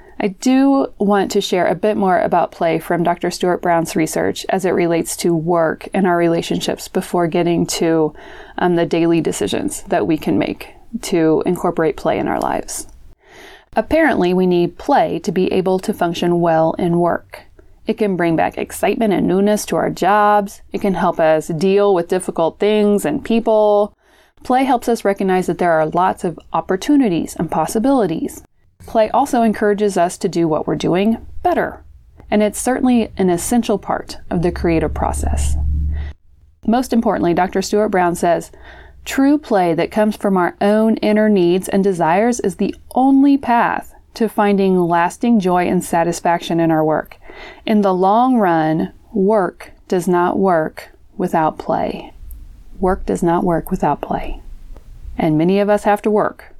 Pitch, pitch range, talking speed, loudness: 185 Hz, 170-215 Hz, 165 wpm, -16 LUFS